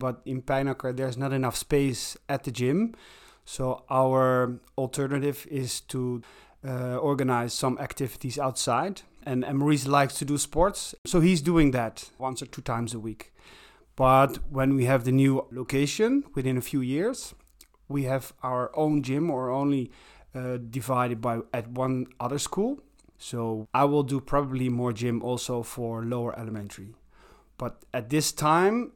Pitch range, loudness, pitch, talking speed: 125-140 Hz, -27 LUFS, 130 Hz, 155 wpm